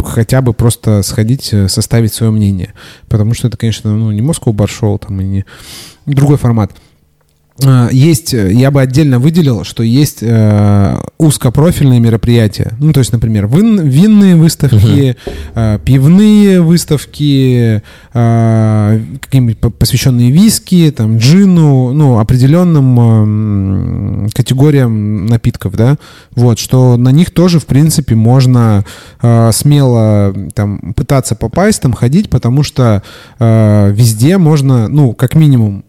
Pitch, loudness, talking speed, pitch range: 120 Hz, -9 LUFS, 115 wpm, 110-140 Hz